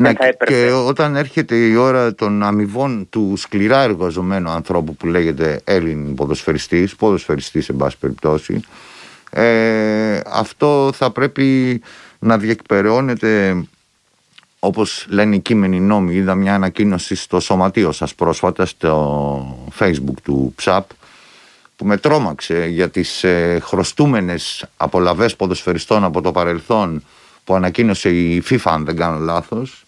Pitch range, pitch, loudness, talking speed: 85-115 Hz, 95 Hz, -16 LUFS, 120 wpm